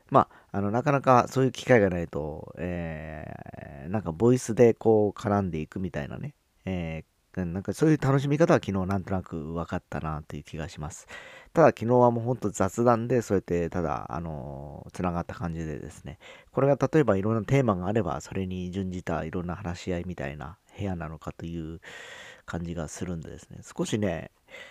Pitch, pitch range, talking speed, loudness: 90 Hz, 80-110 Hz, 395 characters per minute, -27 LUFS